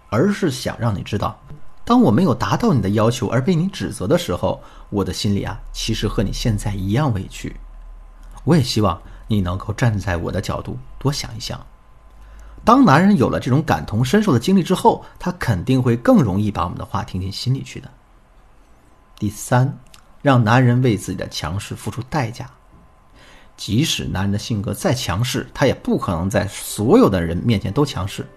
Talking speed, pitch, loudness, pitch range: 275 characters per minute, 110 Hz, -19 LUFS, 100-130 Hz